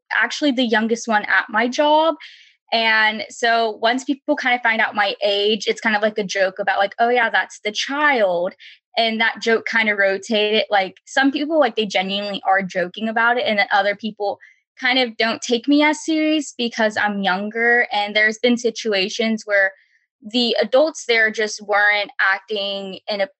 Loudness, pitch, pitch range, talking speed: -18 LUFS, 220 Hz, 205-240 Hz, 185 wpm